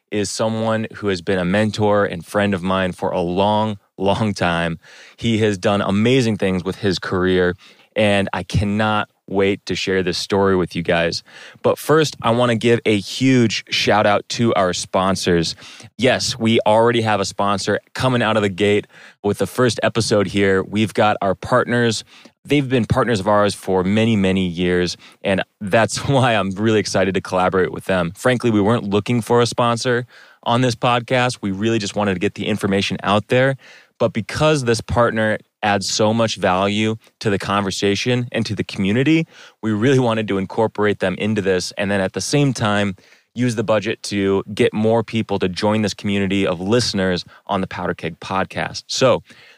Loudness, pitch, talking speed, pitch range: -18 LUFS, 105 Hz, 185 wpm, 95-115 Hz